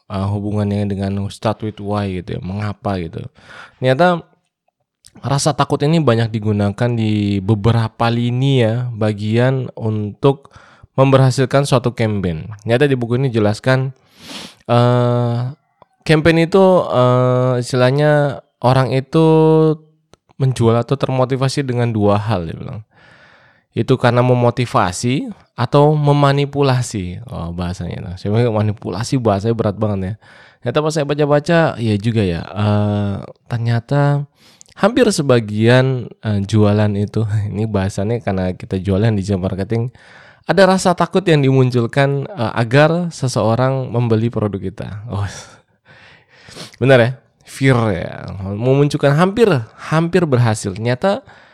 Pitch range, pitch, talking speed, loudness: 105-140 Hz, 120 Hz, 120 wpm, -16 LUFS